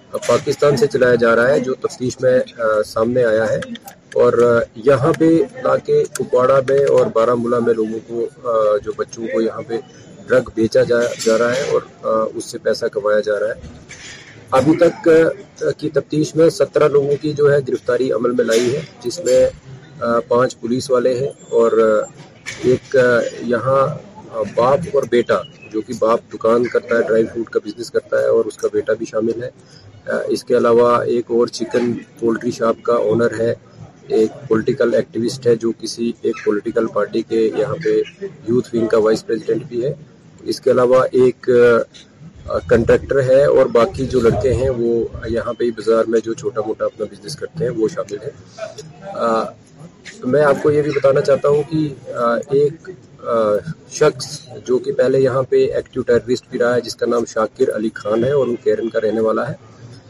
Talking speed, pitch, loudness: 180 wpm, 135 Hz, -17 LUFS